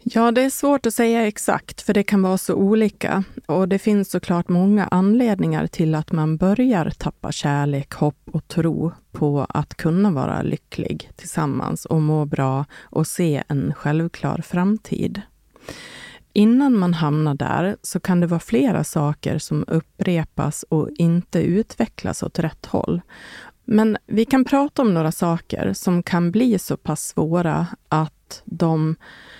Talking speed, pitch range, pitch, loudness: 155 wpm, 155-205 Hz, 175 Hz, -20 LUFS